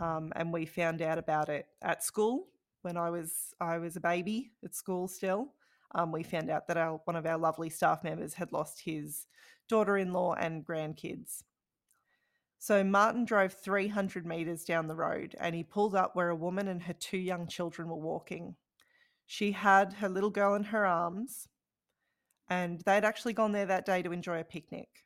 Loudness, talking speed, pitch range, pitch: -33 LUFS, 190 wpm, 165-200 Hz, 180 Hz